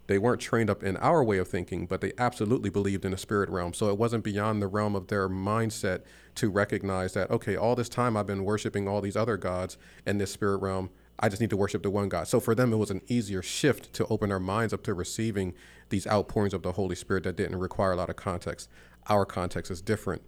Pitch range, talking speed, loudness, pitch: 95-110 Hz, 250 wpm, -29 LUFS, 100 Hz